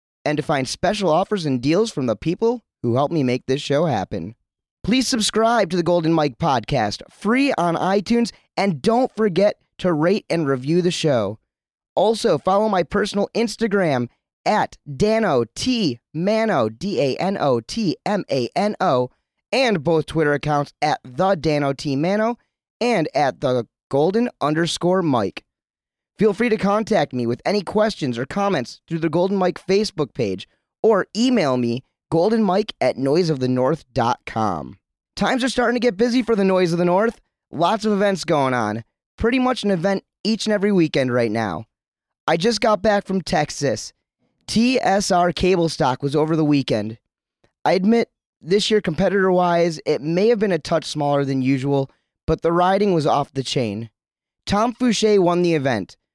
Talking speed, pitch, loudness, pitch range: 170 wpm, 175 Hz, -20 LUFS, 140-210 Hz